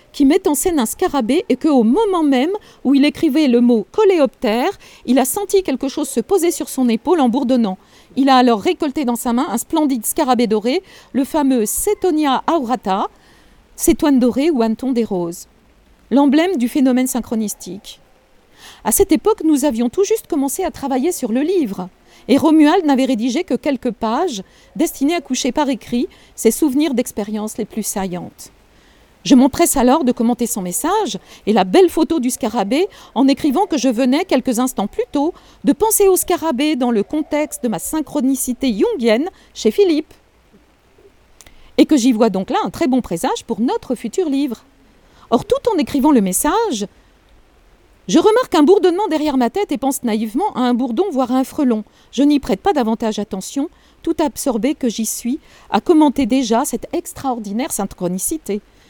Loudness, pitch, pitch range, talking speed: -17 LUFS, 270 Hz, 235-315 Hz, 175 wpm